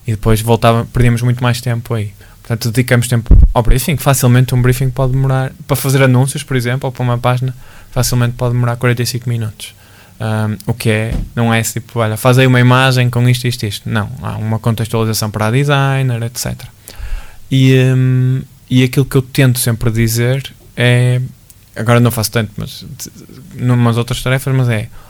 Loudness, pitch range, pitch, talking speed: -13 LUFS, 115-130 Hz, 120 Hz, 180 wpm